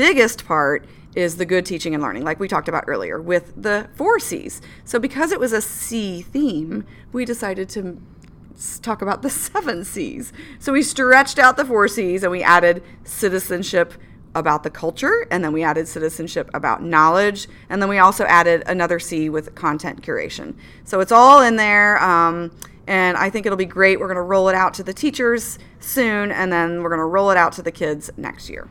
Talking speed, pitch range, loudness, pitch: 205 wpm, 170-225 Hz, -18 LUFS, 190 Hz